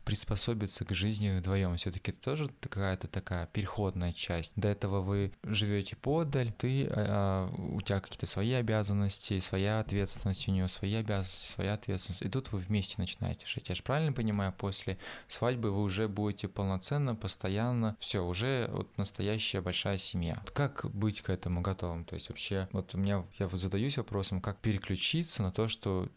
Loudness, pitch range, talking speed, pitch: -33 LUFS, 95-110 Hz, 170 wpm, 100 Hz